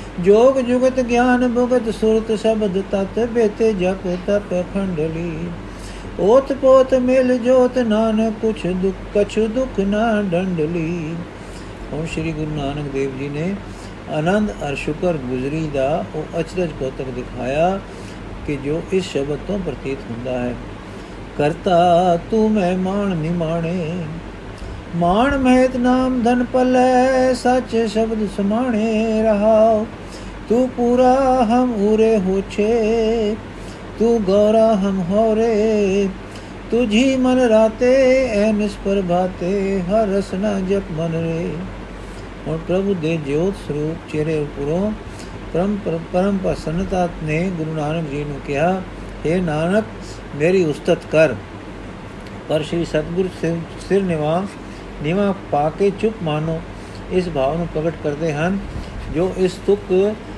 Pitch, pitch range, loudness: 185 Hz, 155-220 Hz, -18 LUFS